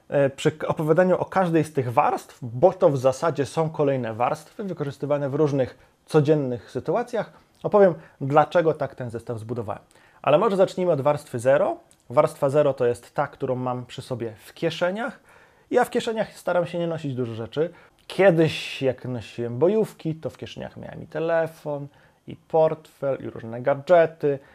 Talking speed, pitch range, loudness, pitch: 160 wpm, 130-170 Hz, -24 LUFS, 150 Hz